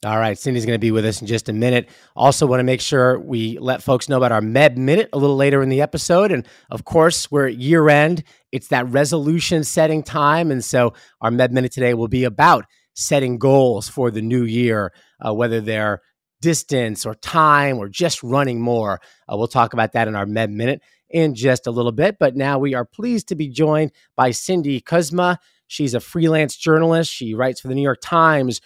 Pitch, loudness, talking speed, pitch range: 130 Hz, -18 LUFS, 220 wpm, 120-155 Hz